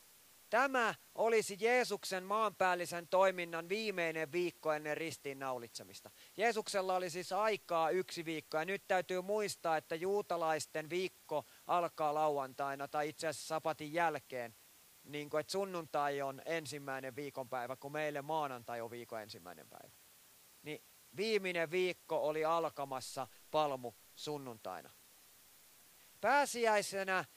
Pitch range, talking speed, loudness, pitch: 140-185 Hz, 110 wpm, -38 LUFS, 160 Hz